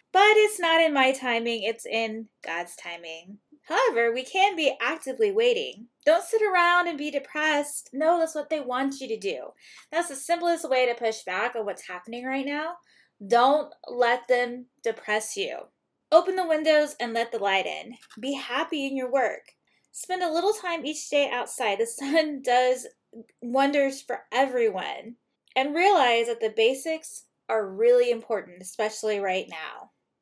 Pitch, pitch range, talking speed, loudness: 270 Hz, 235-330 Hz, 165 wpm, -25 LUFS